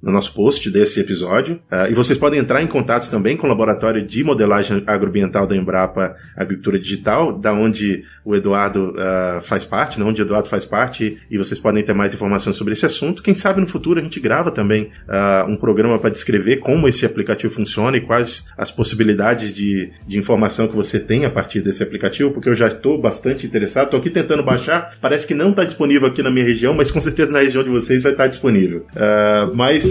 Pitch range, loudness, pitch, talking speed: 100-135 Hz, -17 LUFS, 110 Hz, 215 wpm